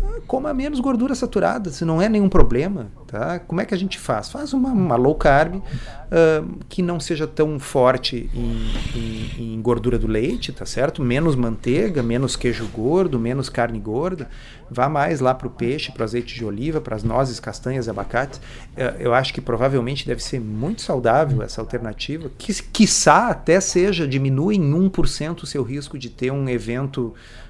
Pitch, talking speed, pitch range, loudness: 135 Hz, 185 wpm, 120-170 Hz, -21 LUFS